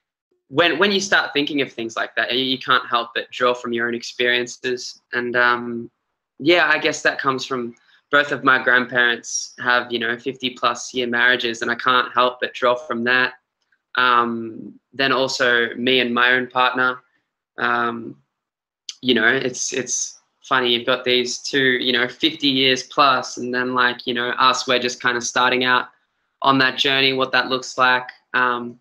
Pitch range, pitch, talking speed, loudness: 120-130 Hz, 125 Hz, 185 wpm, -19 LUFS